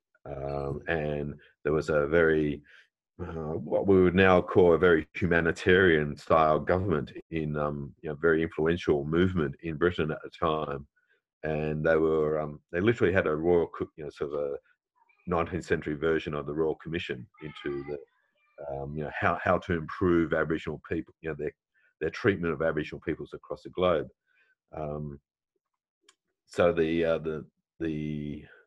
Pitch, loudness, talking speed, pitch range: 80 Hz, -28 LUFS, 165 wpm, 75-85 Hz